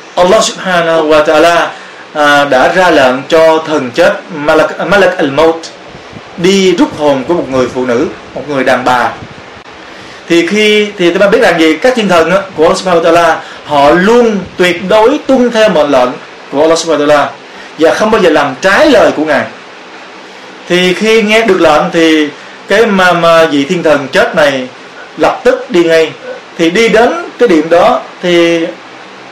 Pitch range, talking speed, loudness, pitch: 155-195 Hz, 180 wpm, -8 LUFS, 170 Hz